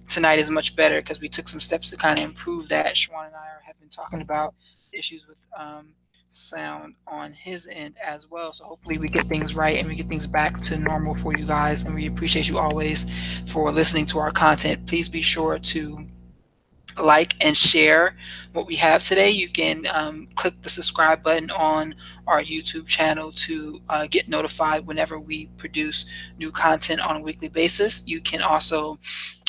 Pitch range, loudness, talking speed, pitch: 155-160 Hz, -21 LUFS, 190 wpm, 155 Hz